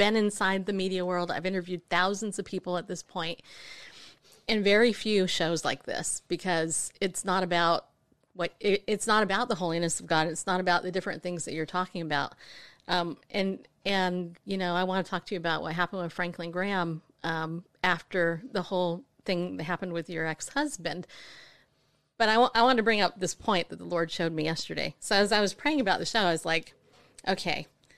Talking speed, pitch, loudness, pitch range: 210 wpm, 180 Hz, -29 LUFS, 170-195 Hz